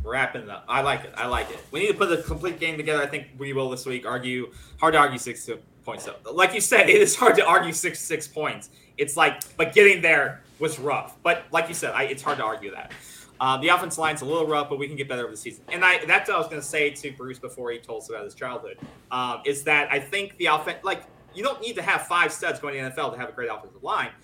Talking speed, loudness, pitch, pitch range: 290 wpm, -23 LUFS, 150 Hz, 135-180 Hz